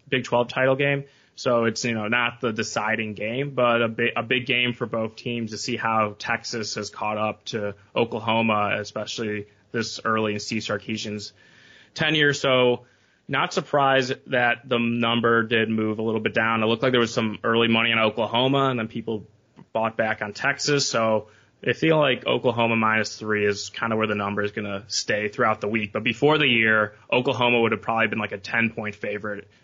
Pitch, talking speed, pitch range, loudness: 115 Hz, 200 wpm, 105-120 Hz, -23 LUFS